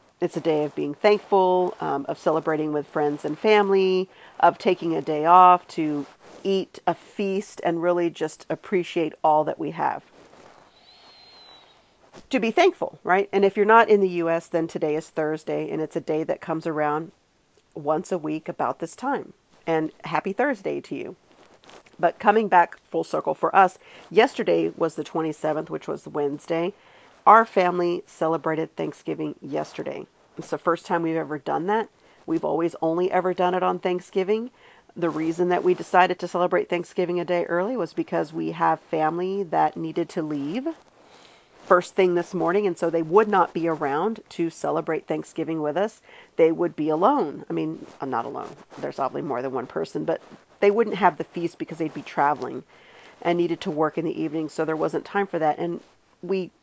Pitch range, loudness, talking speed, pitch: 160-190 Hz, -24 LUFS, 185 wpm, 170 Hz